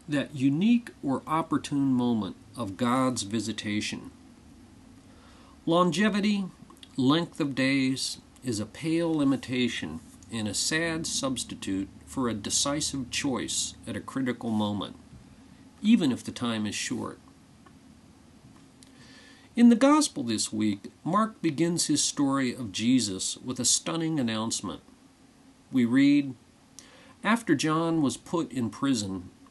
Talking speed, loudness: 115 wpm, -27 LUFS